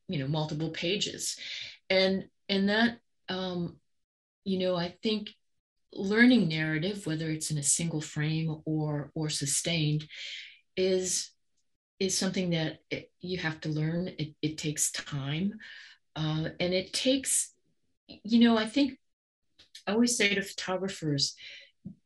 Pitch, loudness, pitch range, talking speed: 180 Hz, -30 LUFS, 155-195 Hz, 135 wpm